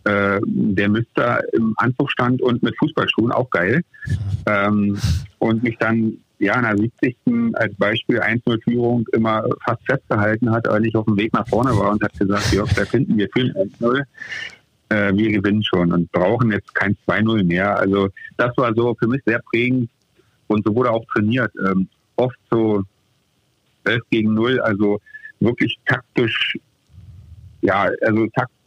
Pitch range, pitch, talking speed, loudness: 105-120 Hz, 110 Hz, 165 wpm, -19 LUFS